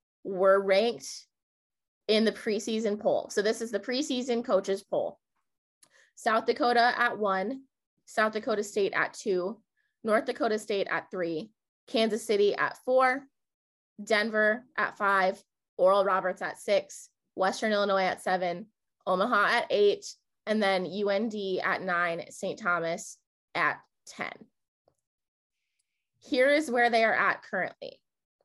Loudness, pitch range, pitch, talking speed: -28 LUFS, 195-250 Hz, 215 Hz, 130 wpm